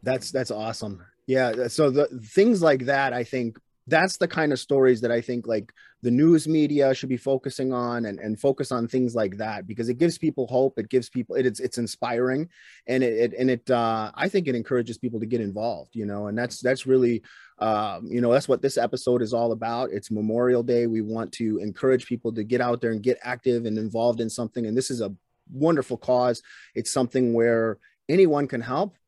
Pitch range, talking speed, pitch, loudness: 115-130 Hz, 220 wpm, 125 Hz, -24 LUFS